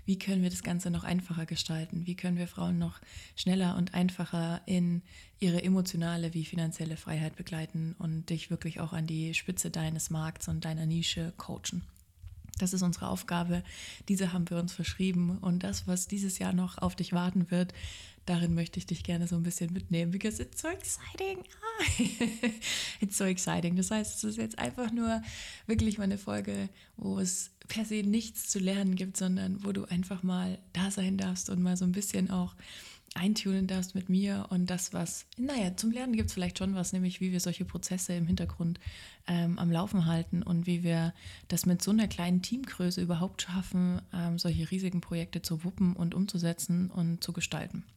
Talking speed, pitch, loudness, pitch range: 190 wpm, 180 Hz, -33 LUFS, 170-190 Hz